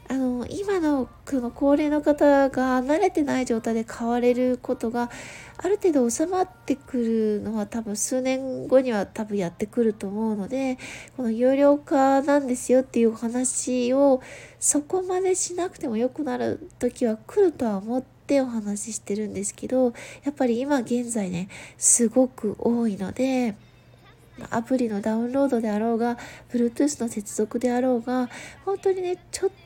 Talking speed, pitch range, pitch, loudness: 325 characters per minute, 230-280 Hz, 250 Hz, -24 LUFS